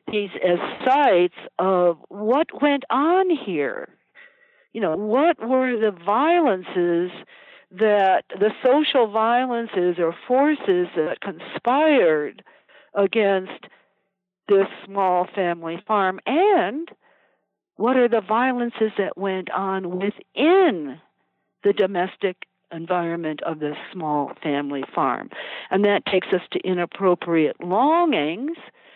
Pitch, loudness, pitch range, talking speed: 205 Hz, -21 LUFS, 180-275 Hz, 105 wpm